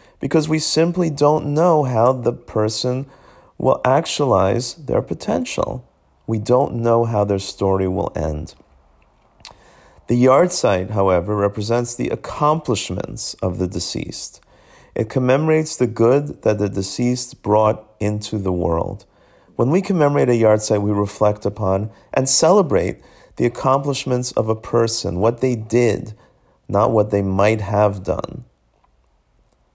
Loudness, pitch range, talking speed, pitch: -18 LUFS, 95-125 Hz, 135 wpm, 110 Hz